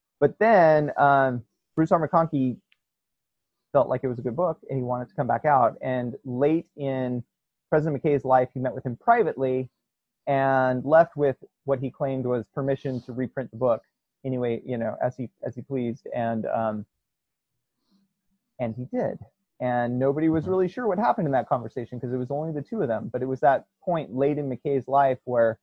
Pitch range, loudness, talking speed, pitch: 125-145 Hz, -25 LUFS, 195 wpm, 130 Hz